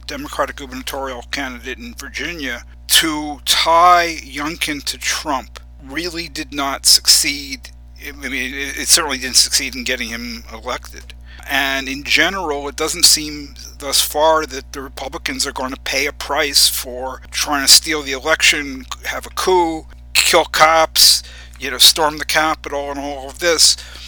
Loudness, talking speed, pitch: -14 LUFS, 150 wpm, 135 Hz